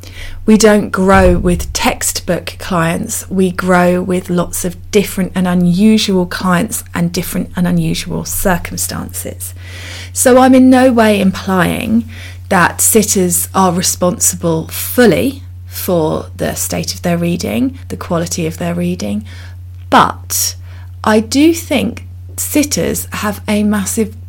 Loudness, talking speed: -13 LUFS, 125 wpm